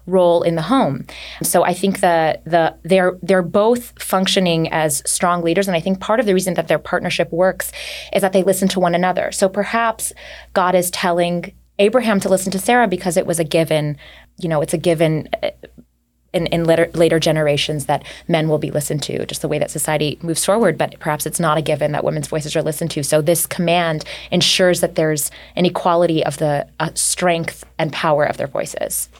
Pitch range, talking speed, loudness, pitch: 155-185 Hz, 210 wpm, -17 LUFS, 170 Hz